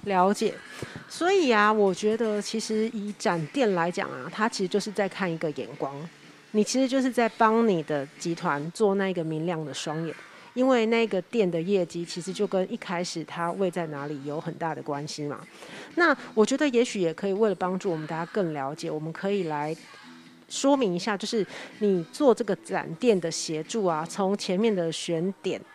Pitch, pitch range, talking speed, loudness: 190 Hz, 165-215 Hz, 280 characters per minute, -27 LUFS